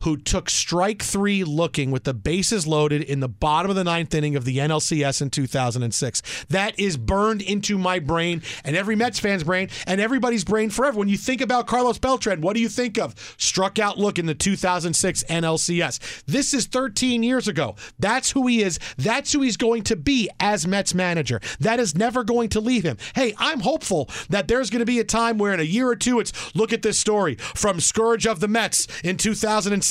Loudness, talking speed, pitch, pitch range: -22 LUFS, 215 wpm, 200 Hz, 160-230 Hz